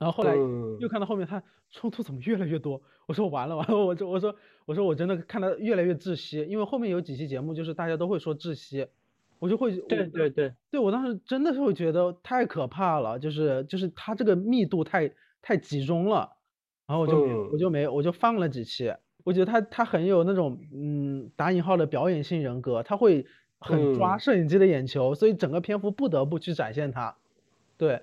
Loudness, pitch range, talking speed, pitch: -27 LUFS, 150-200 Hz, 315 characters per minute, 175 Hz